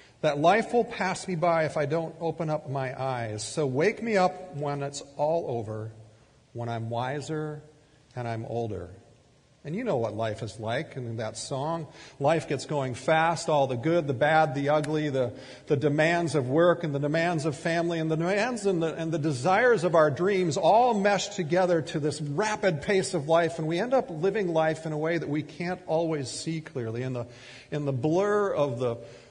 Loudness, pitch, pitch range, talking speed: -27 LUFS, 155 Hz, 130-170 Hz, 215 wpm